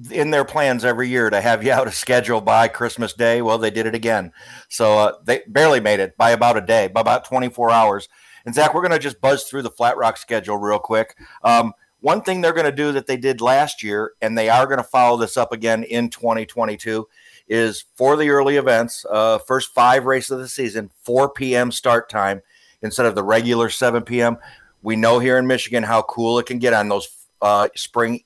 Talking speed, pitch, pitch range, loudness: 225 wpm, 120 Hz, 110-130 Hz, -18 LUFS